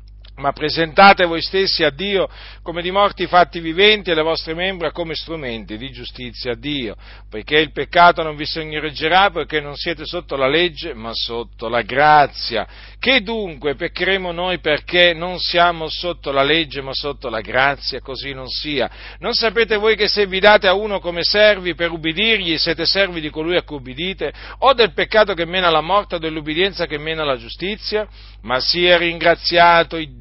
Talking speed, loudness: 180 wpm, -17 LUFS